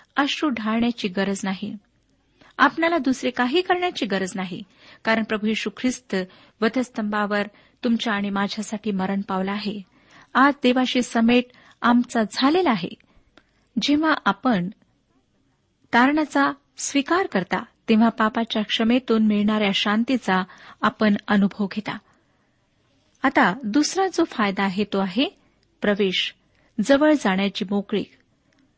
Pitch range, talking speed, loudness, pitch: 205-265 Hz, 105 wpm, -22 LUFS, 225 Hz